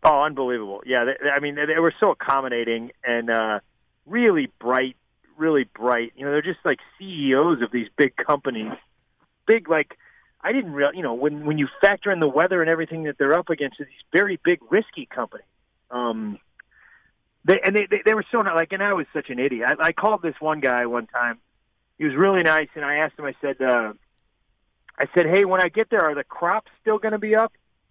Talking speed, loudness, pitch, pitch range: 225 wpm, -22 LUFS, 150 Hz, 125-185 Hz